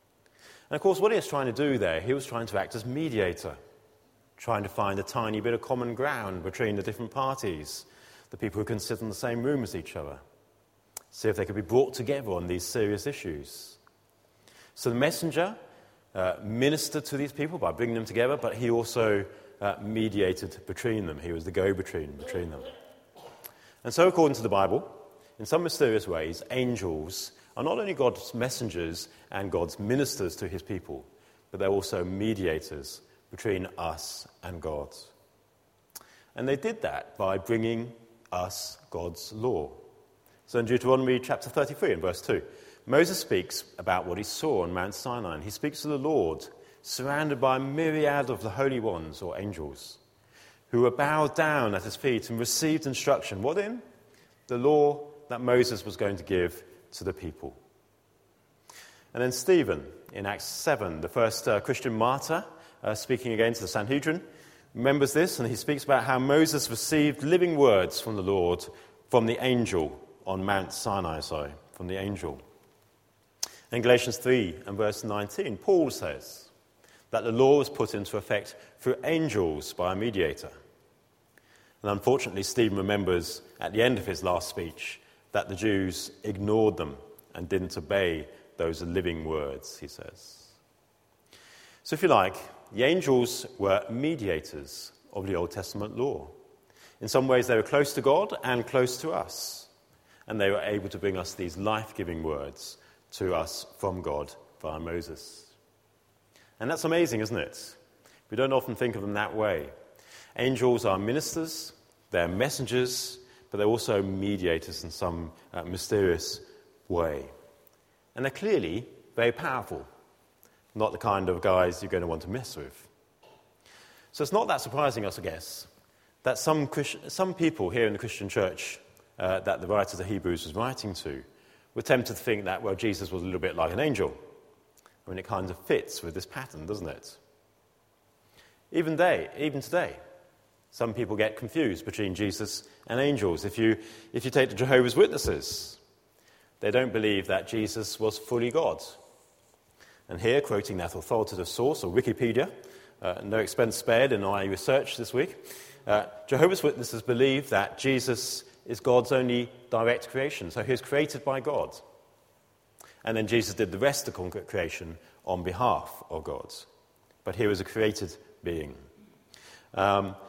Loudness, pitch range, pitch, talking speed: -29 LUFS, 100-135 Hz, 115 Hz, 170 wpm